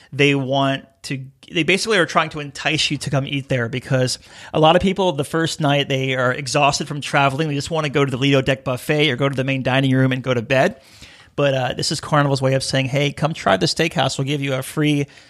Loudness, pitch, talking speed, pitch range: -19 LUFS, 140 Hz, 260 wpm, 135-150 Hz